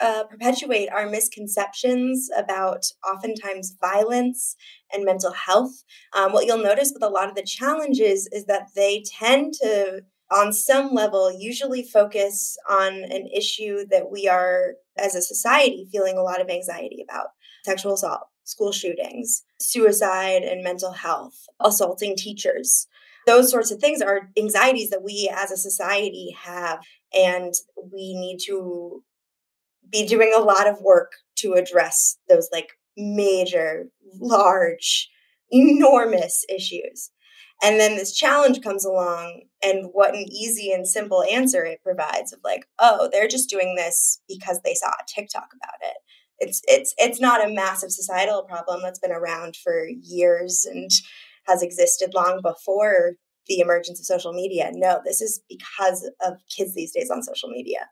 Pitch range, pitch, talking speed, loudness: 185-245 Hz, 200 Hz, 155 wpm, -21 LUFS